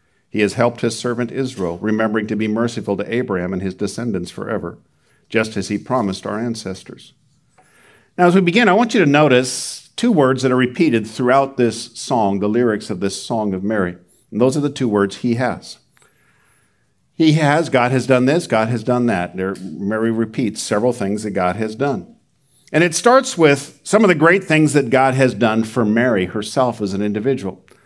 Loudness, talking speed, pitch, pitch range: -17 LUFS, 195 wpm, 120 Hz, 105-135 Hz